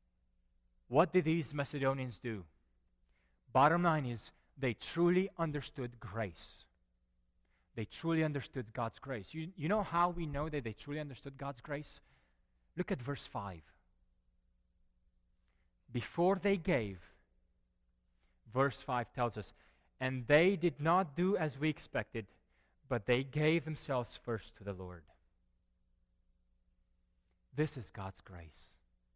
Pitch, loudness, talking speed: 110 Hz, -36 LUFS, 125 wpm